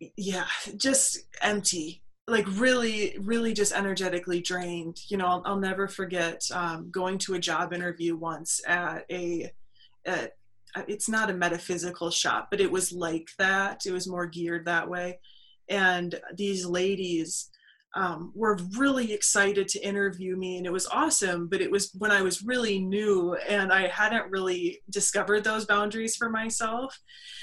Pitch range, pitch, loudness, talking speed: 175-205 Hz, 190 Hz, -27 LUFS, 160 wpm